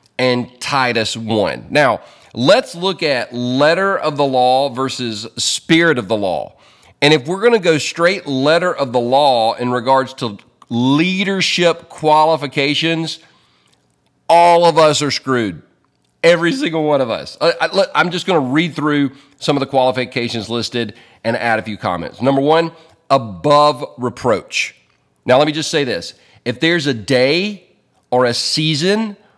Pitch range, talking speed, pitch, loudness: 125-165 Hz, 155 wpm, 145 Hz, -15 LUFS